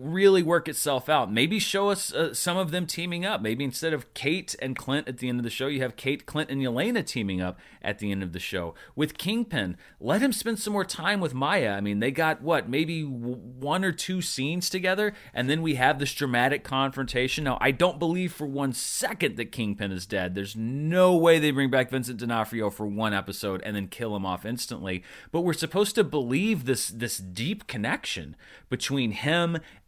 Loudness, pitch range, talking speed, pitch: -27 LUFS, 115-170 Hz, 215 wpm, 140 Hz